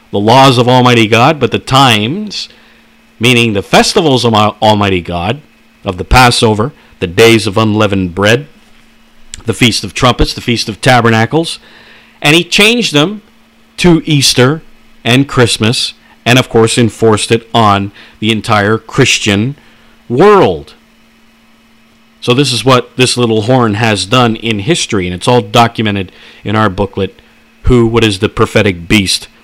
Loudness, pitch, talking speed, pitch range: -9 LUFS, 115 Hz, 145 wpm, 110-125 Hz